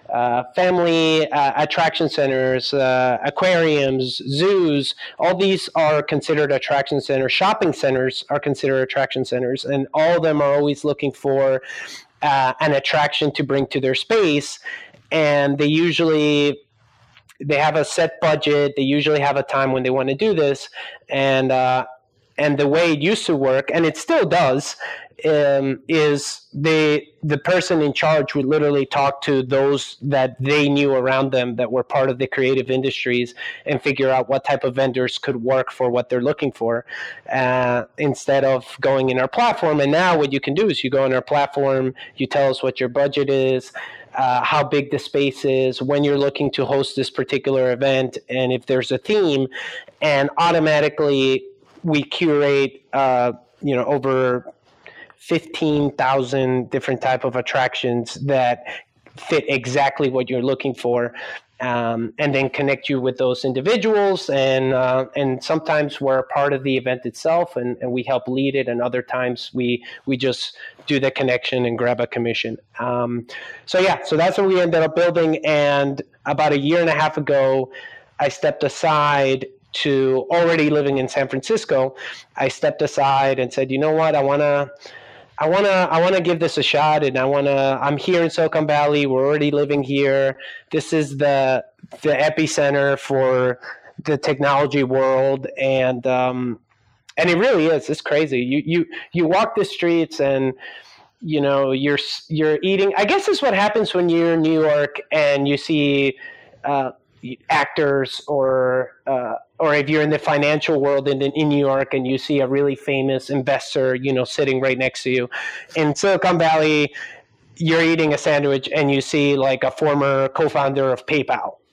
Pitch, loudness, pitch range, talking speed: 140 Hz, -19 LUFS, 130-150 Hz, 175 wpm